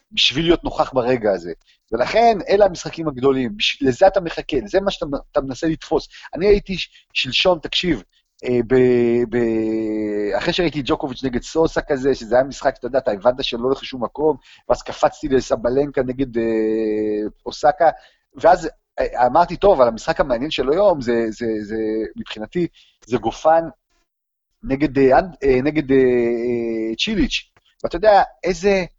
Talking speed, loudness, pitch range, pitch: 150 wpm, -19 LUFS, 120-165 Hz, 135 Hz